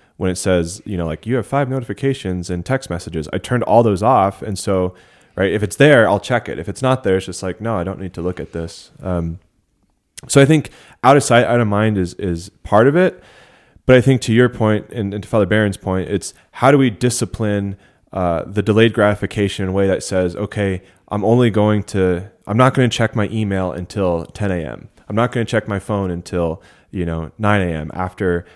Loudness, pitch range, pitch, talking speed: -17 LUFS, 90-115 Hz, 100 Hz, 235 wpm